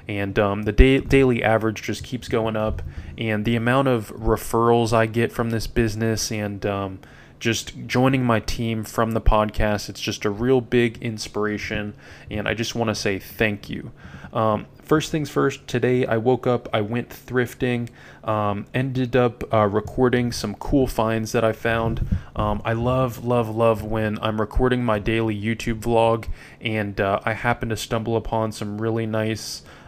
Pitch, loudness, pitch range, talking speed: 115 Hz, -22 LUFS, 105-120 Hz, 175 wpm